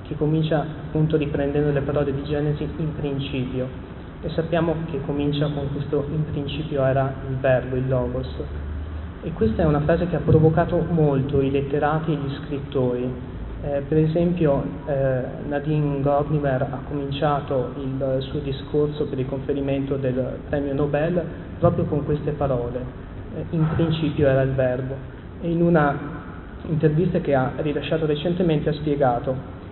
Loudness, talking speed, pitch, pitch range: -23 LUFS, 150 wpm, 145 Hz, 135-155 Hz